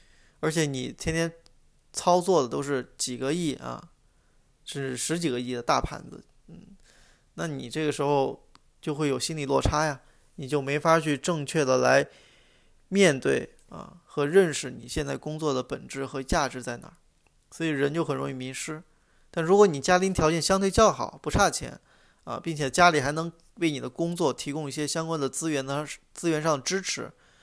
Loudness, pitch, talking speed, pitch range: -26 LUFS, 150 Hz, 260 characters per minute, 135-165 Hz